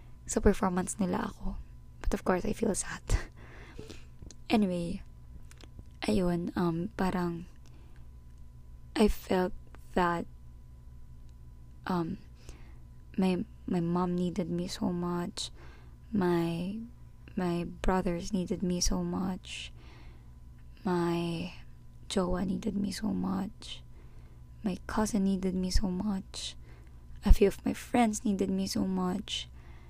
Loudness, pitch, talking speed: -32 LUFS, 175 Hz, 105 wpm